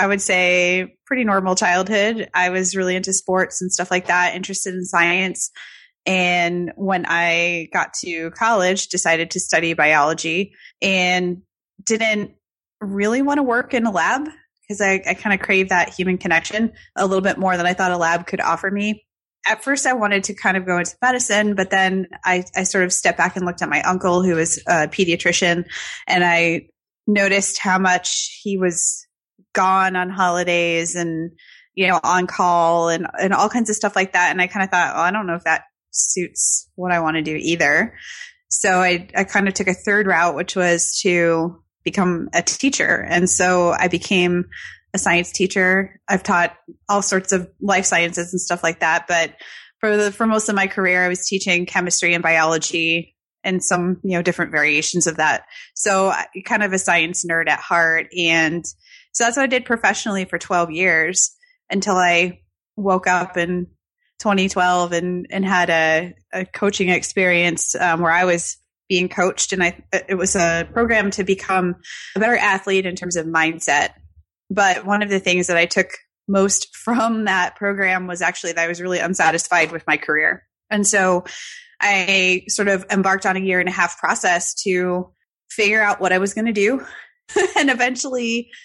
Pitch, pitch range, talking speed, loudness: 185 Hz, 175-200 Hz, 190 wpm, -18 LUFS